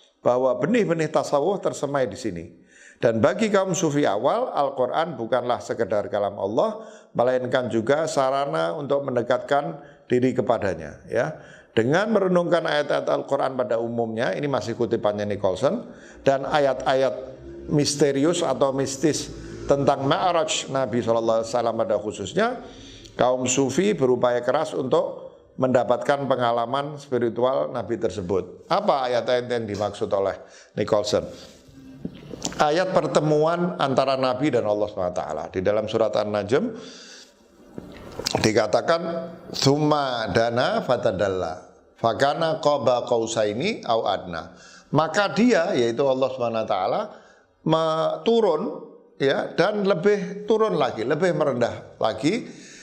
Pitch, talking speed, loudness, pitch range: 135 Hz, 110 wpm, -23 LUFS, 120-160 Hz